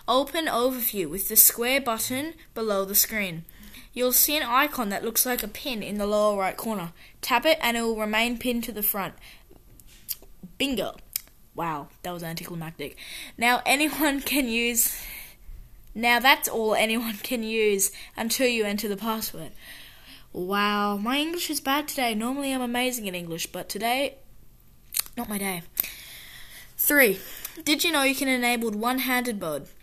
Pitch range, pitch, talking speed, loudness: 205-255 Hz, 230 Hz, 160 wpm, -24 LUFS